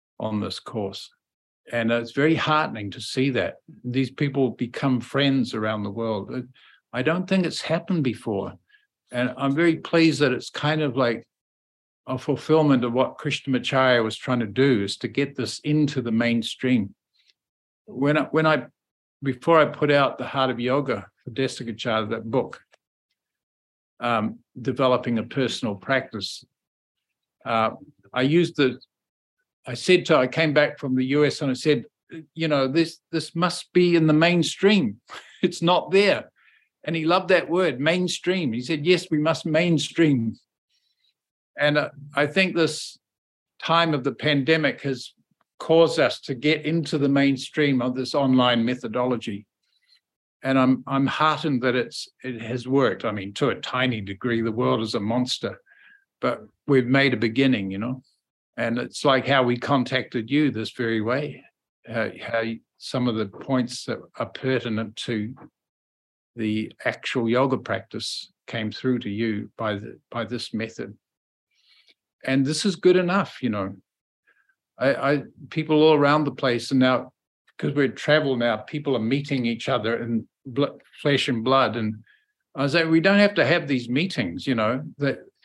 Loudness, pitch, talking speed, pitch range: -23 LUFS, 135 Hz, 165 wpm, 120-155 Hz